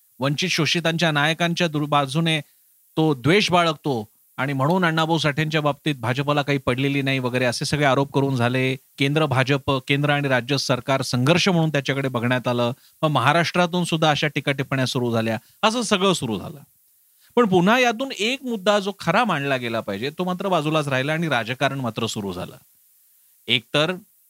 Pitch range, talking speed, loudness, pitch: 130-165 Hz, 160 wpm, -21 LUFS, 145 Hz